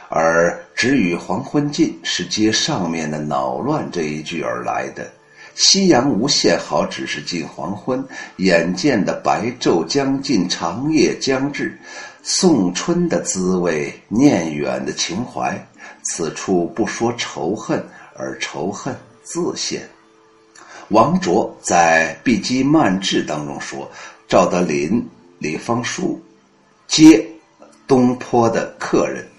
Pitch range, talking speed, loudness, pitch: 80-135 Hz, 170 characters per minute, -18 LUFS, 95 Hz